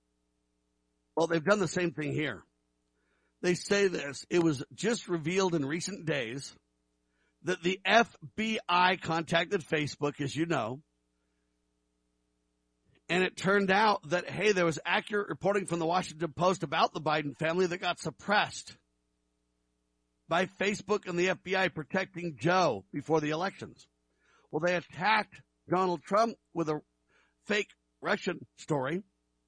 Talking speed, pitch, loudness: 135 wpm, 160 Hz, -30 LUFS